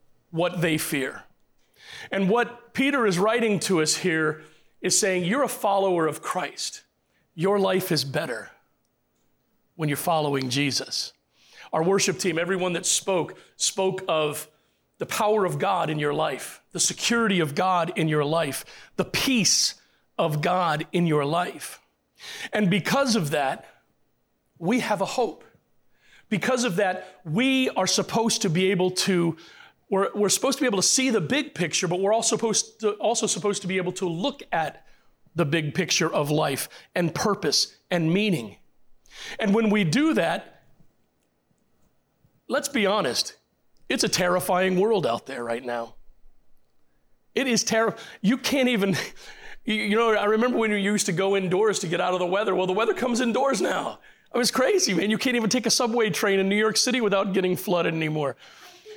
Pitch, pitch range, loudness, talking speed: 190 Hz, 165-220 Hz, -24 LUFS, 175 wpm